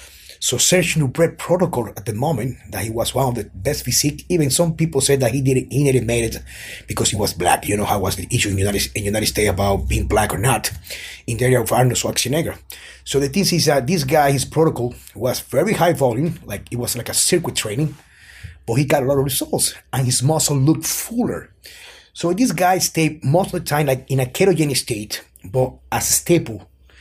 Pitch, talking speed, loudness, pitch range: 130 Hz, 225 wpm, -19 LUFS, 110-160 Hz